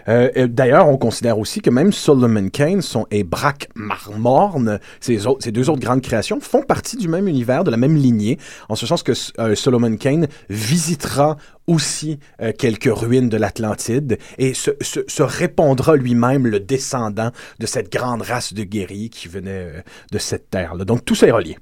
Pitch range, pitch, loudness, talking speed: 110-145 Hz, 125 Hz, -18 LUFS, 185 wpm